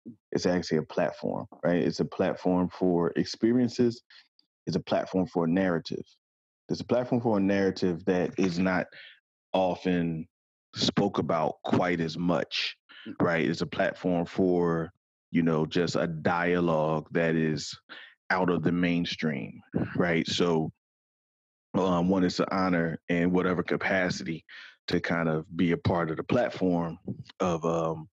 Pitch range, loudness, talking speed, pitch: 85-95 Hz, -28 LUFS, 145 wpm, 85 Hz